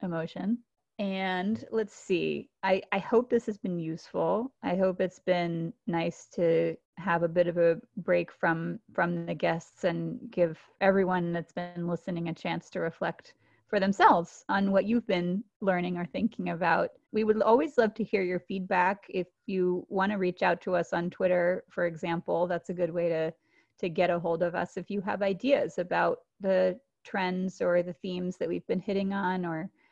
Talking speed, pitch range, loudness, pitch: 190 wpm, 175-195 Hz, -29 LUFS, 185 Hz